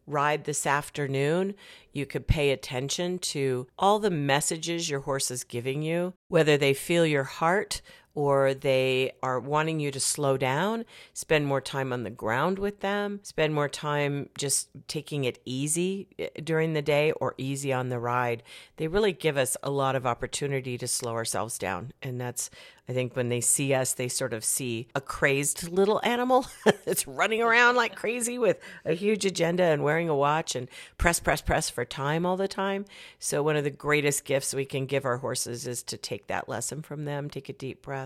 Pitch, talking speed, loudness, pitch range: 145 Hz, 195 wpm, -27 LUFS, 130-165 Hz